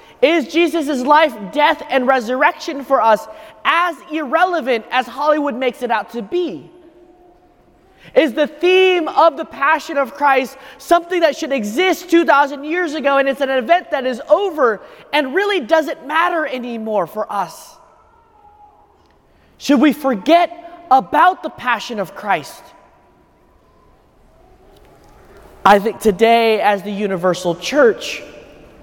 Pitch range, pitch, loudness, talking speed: 255-340 Hz, 300 Hz, -16 LUFS, 125 wpm